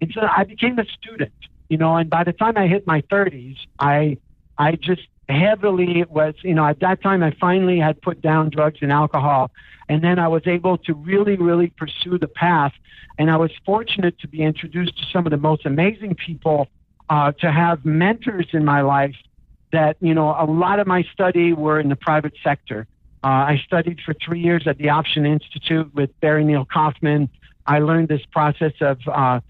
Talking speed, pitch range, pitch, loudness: 200 wpm, 150-175 Hz, 160 Hz, -19 LUFS